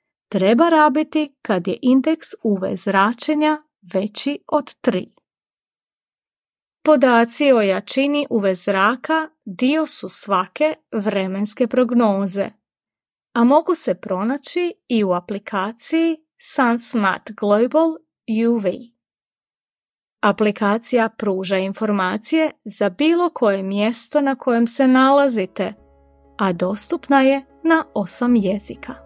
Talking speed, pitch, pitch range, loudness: 95 wpm, 235 Hz, 200-295 Hz, -19 LUFS